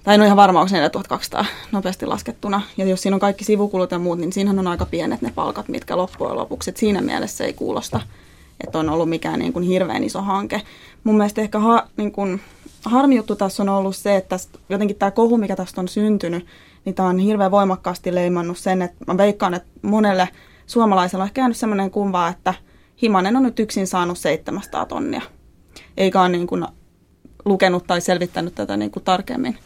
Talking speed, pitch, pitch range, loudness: 200 wpm, 195 Hz, 180-210 Hz, -20 LUFS